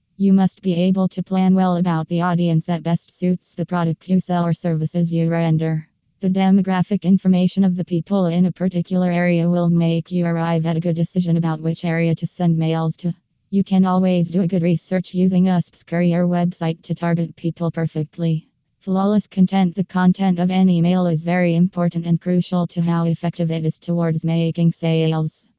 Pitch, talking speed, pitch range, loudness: 175 Hz, 190 wpm, 165-185 Hz, -19 LUFS